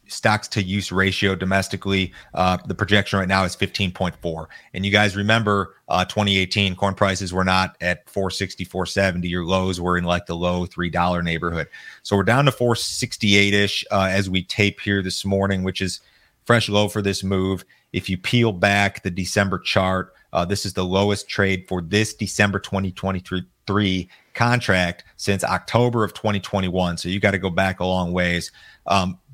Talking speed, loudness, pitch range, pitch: 200 wpm, -21 LUFS, 90-100 Hz, 95 Hz